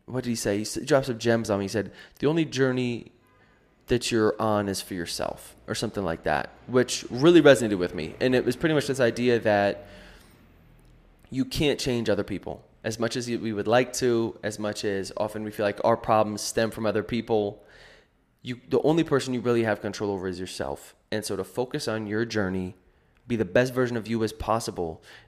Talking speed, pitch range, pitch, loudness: 210 wpm, 105-125 Hz, 115 Hz, -26 LUFS